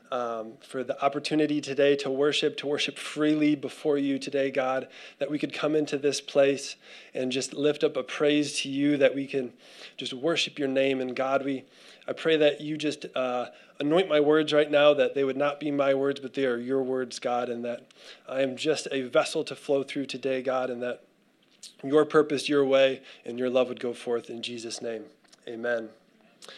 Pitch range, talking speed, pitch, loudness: 130-145 Hz, 205 wpm, 140 Hz, -27 LUFS